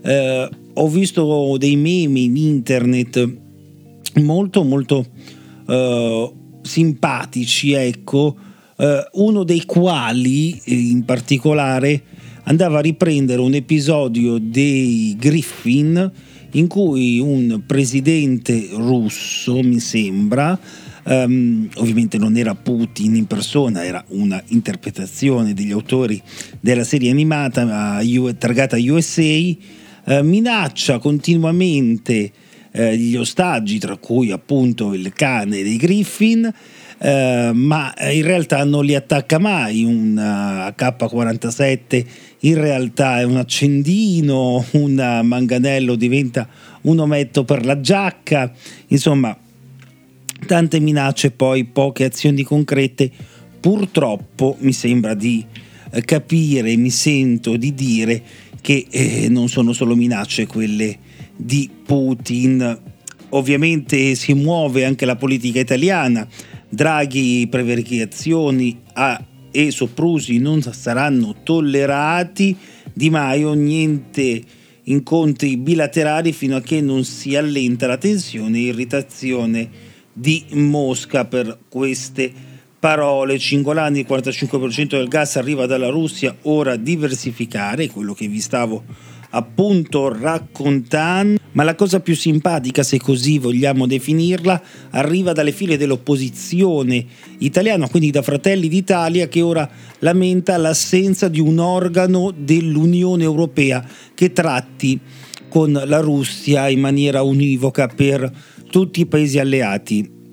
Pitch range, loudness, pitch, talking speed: 125-155 Hz, -17 LUFS, 140 Hz, 110 wpm